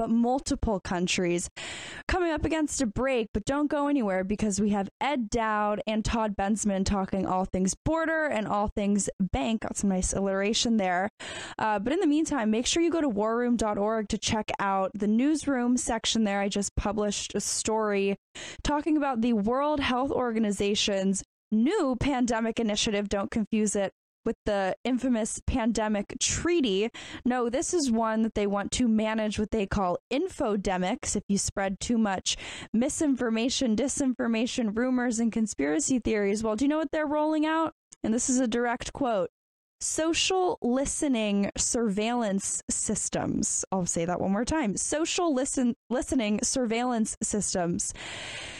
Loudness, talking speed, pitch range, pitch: -28 LUFS, 155 wpm, 205-265 Hz, 225 Hz